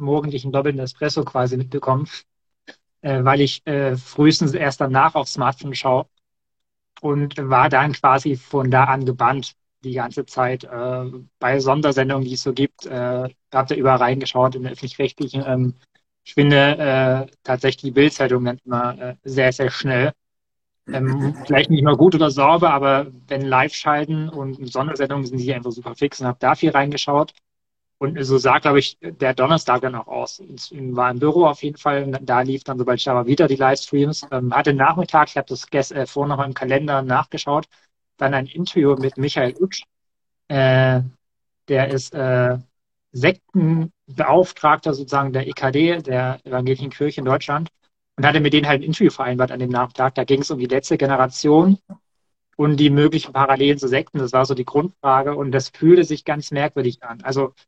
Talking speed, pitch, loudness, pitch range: 180 wpm, 135 Hz, -19 LUFS, 130-145 Hz